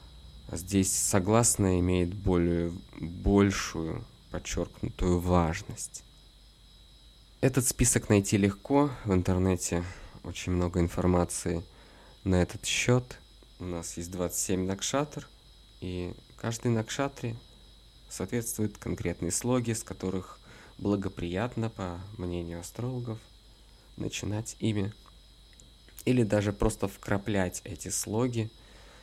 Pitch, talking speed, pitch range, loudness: 100 Hz, 90 wpm, 90-115 Hz, -30 LUFS